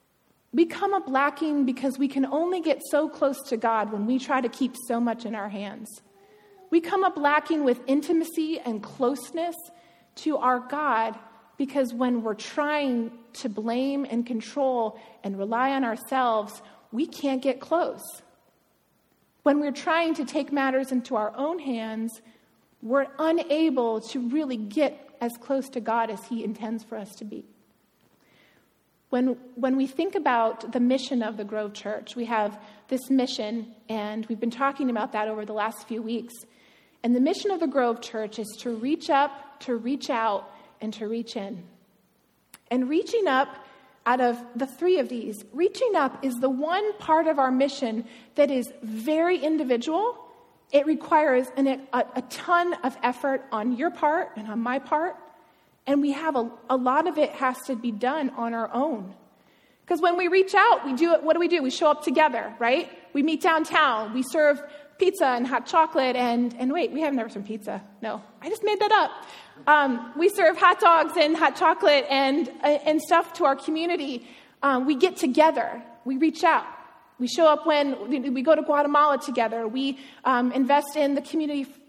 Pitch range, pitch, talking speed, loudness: 235-310 Hz, 270 Hz, 180 wpm, -25 LUFS